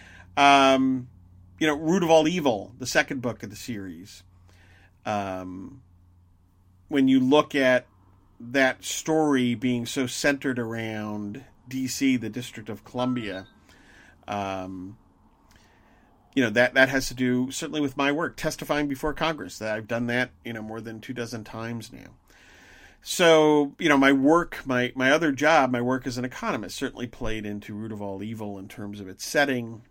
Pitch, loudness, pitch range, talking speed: 125 Hz, -24 LUFS, 105-135 Hz, 165 wpm